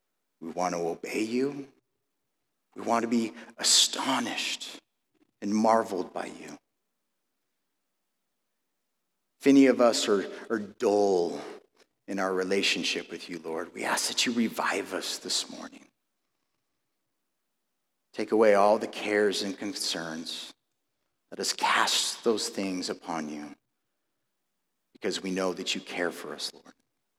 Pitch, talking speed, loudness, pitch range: 100 Hz, 130 wpm, -27 LUFS, 90-115 Hz